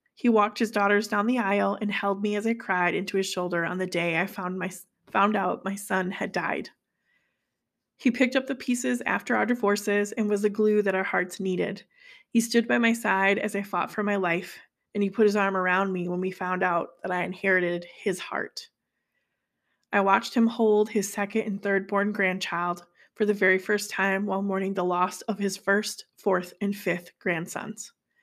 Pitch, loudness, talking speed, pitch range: 200 Hz, -26 LUFS, 205 wpm, 185-215 Hz